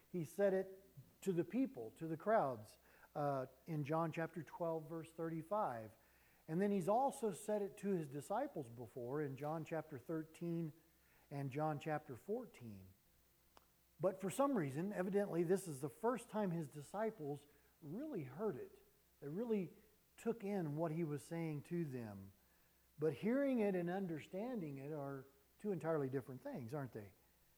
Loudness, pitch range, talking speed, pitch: -43 LUFS, 145-195 Hz, 155 wpm, 165 Hz